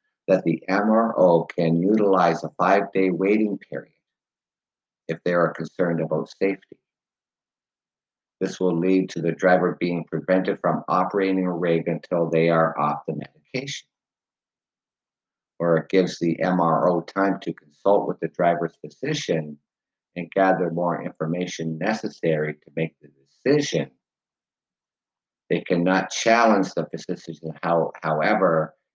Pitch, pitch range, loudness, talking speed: 85 Hz, 80-95 Hz, -23 LUFS, 125 wpm